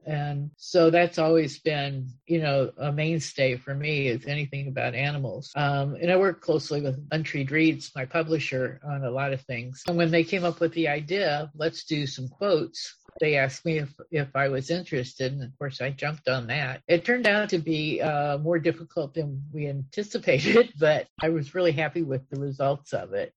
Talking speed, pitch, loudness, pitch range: 200 wpm, 150 Hz, -26 LUFS, 140-165 Hz